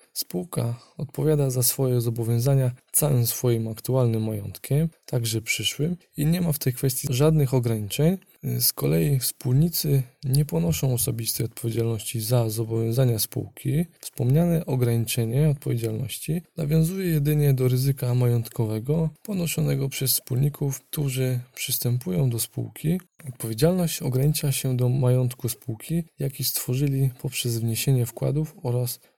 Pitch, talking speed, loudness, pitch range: 130 Hz, 115 wpm, -24 LUFS, 120-150 Hz